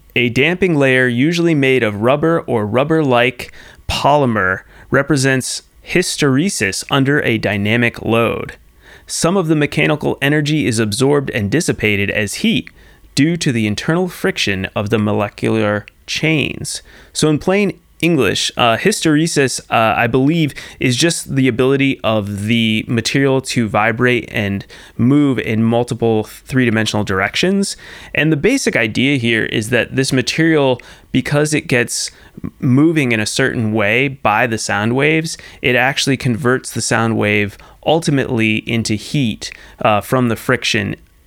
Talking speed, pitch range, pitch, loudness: 140 wpm, 110-145 Hz, 125 Hz, -15 LUFS